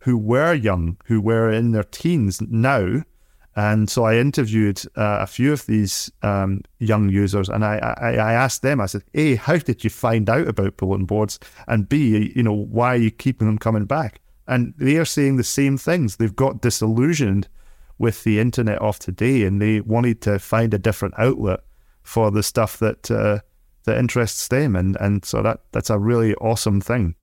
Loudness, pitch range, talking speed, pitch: -20 LUFS, 105-125 Hz, 195 wpm, 110 Hz